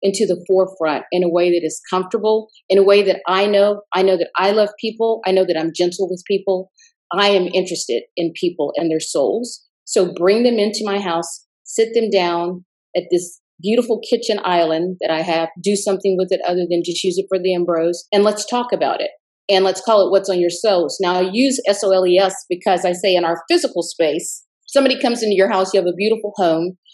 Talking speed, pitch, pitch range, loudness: 230 wpm, 190 Hz, 175-210 Hz, -17 LUFS